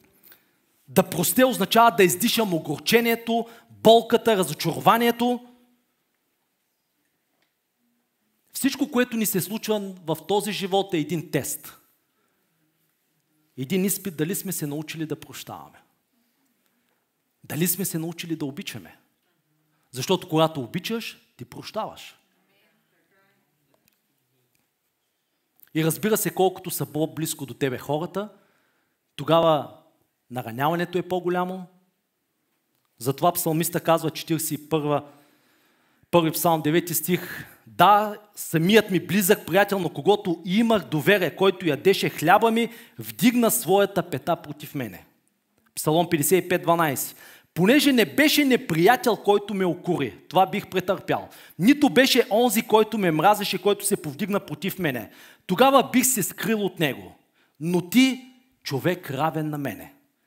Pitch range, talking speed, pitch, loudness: 155-210 Hz, 110 wpm, 180 Hz, -22 LUFS